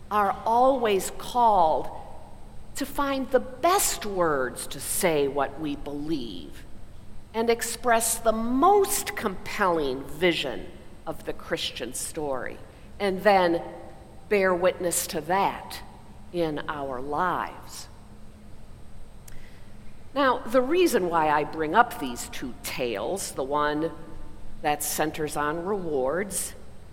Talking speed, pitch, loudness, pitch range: 105 wpm, 180 Hz, -26 LUFS, 150-230 Hz